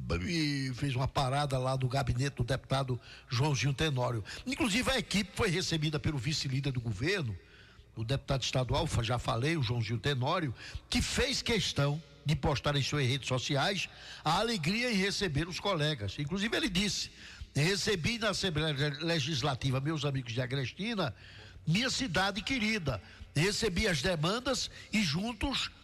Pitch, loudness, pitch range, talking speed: 145 Hz, -32 LUFS, 130-185 Hz, 145 wpm